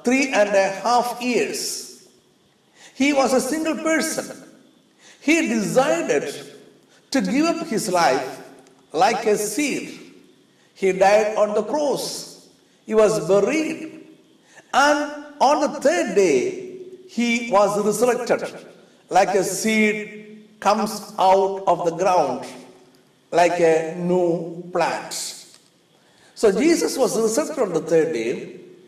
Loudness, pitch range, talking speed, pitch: -20 LUFS, 195-300 Hz, 115 wpm, 220 Hz